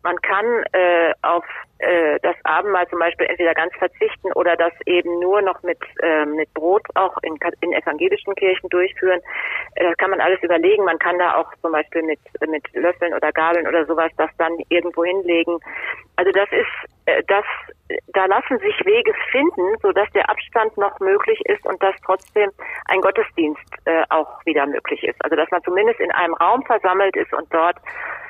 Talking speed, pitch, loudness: 185 wpm, 185 Hz, -19 LUFS